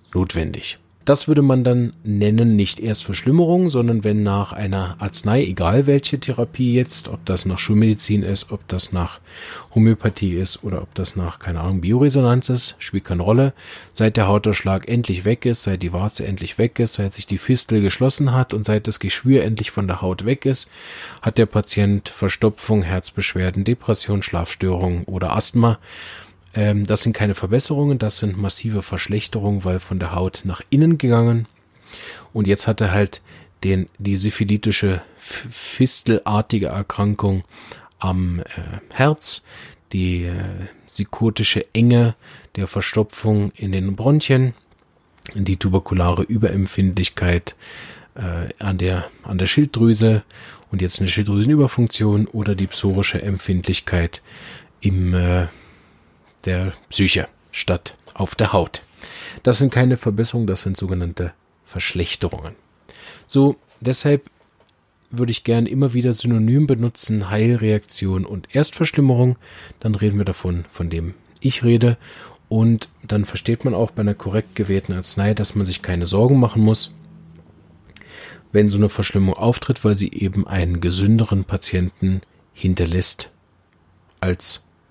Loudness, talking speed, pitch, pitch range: -19 LUFS, 140 wpm, 105 Hz, 95-115 Hz